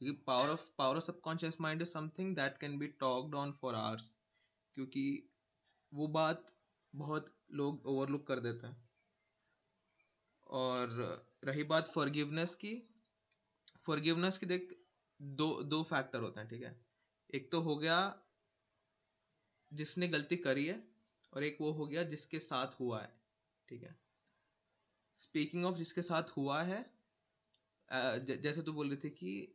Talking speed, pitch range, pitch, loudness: 145 wpm, 130-165 Hz, 145 Hz, -39 LUFS